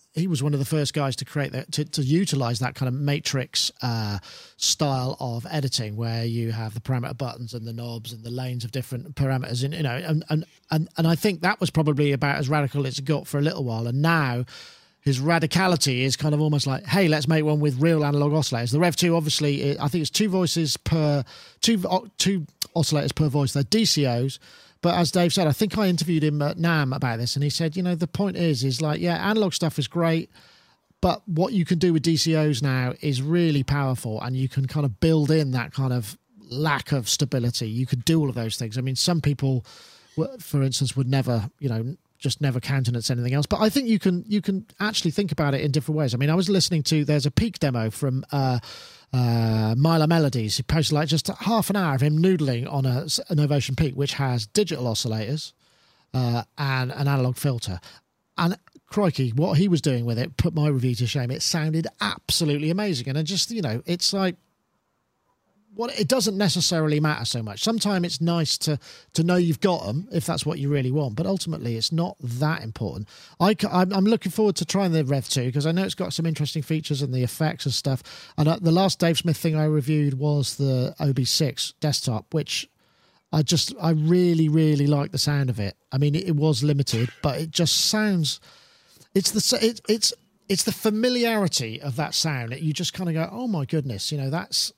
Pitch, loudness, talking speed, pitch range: 150 Hz, -24 LUFS, 220 wpm, 135-170 Hz